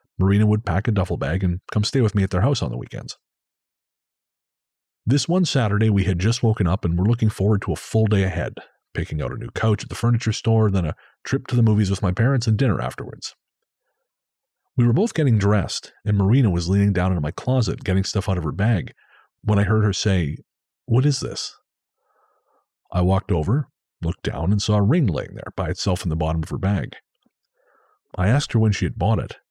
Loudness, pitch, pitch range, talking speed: -21 LUFS, 105 Hz, 95-115 Hz, 220 wpm